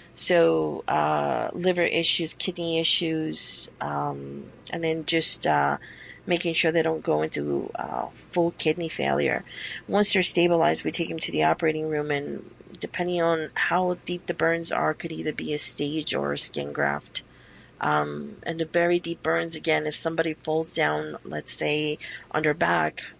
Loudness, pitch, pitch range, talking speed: -26 LUFS, 160 Hz, 125-170 Hz, 165 wpm